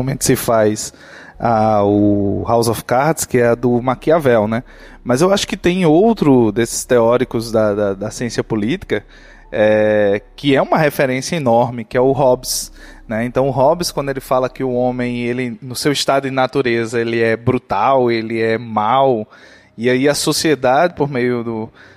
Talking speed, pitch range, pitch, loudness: 180 wpm, 115-135 Hz, 125 Hz, -16 LUFS